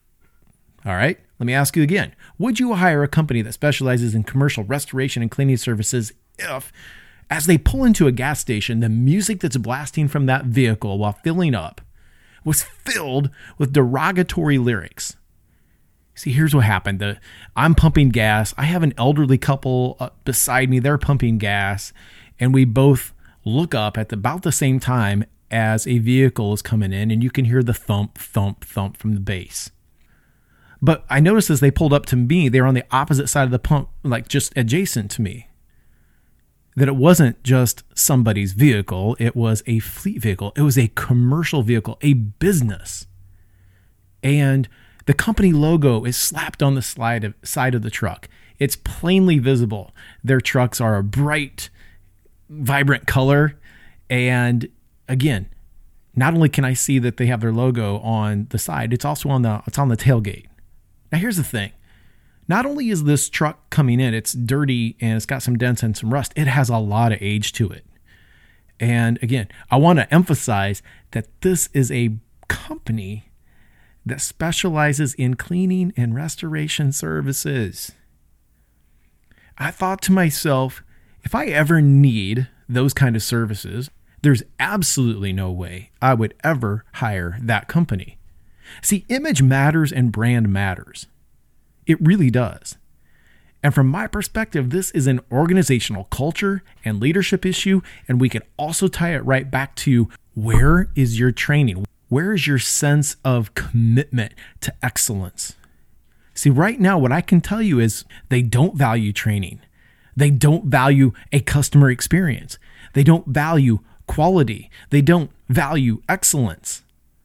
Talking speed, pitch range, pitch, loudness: 160 wpm, 105-145 Hz, 125 Hz, -19 LUFS